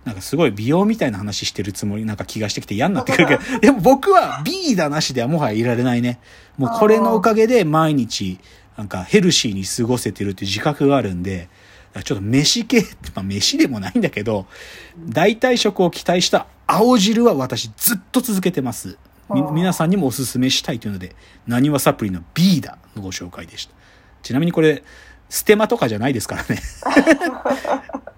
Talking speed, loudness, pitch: 390 characters per minute, -18 LUFS, 135 Hz